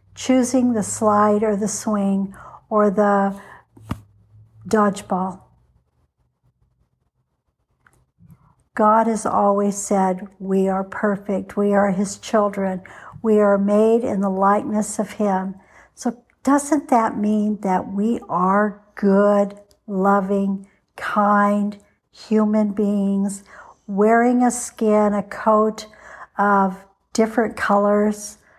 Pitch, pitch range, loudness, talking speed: 205 Hz, 195-215 Hz, -19 LUFS, 100 wpm